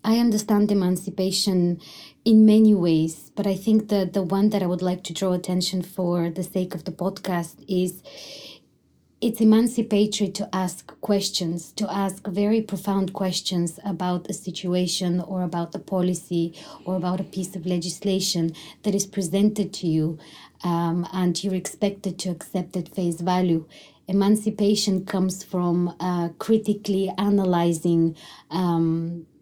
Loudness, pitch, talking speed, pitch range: -24 LUFS, 185 Hz, 145 wpm, 175-200 Hz